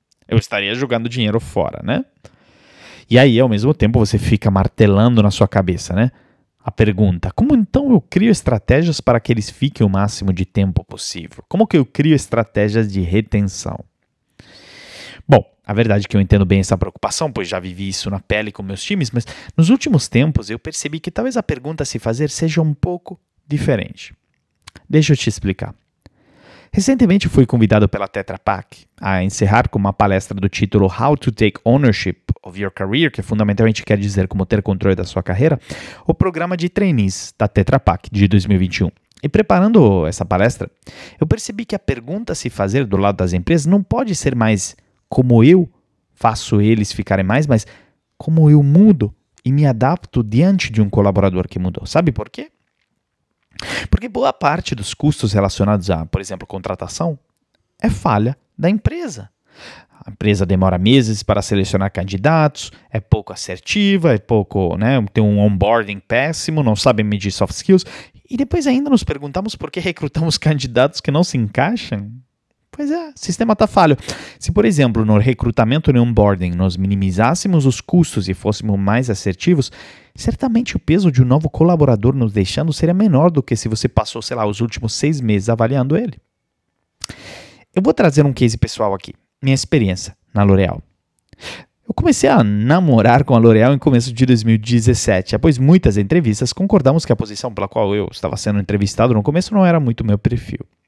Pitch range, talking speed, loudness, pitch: 100-150 Hz, 175 wpm, -16 LUFS, 115 Hz